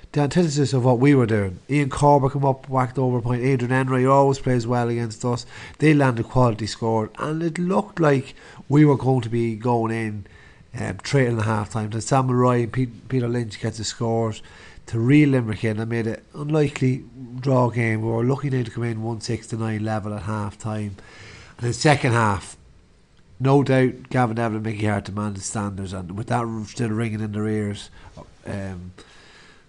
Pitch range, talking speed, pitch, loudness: 110-130 Hz, 195 wpm, 120 Hz, -22 LUFS